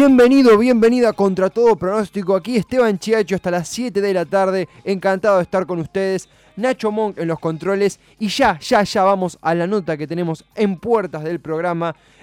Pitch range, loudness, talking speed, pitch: 175-220 Hz, -18 LUFS, 185 wpm, 195 Hz